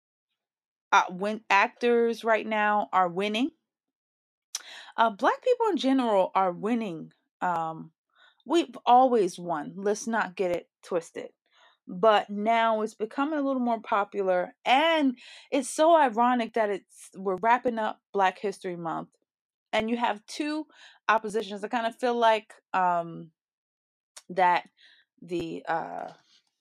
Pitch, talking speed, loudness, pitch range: 220 Hz, 130 wpm, -26 LUFS, 190-245 Hz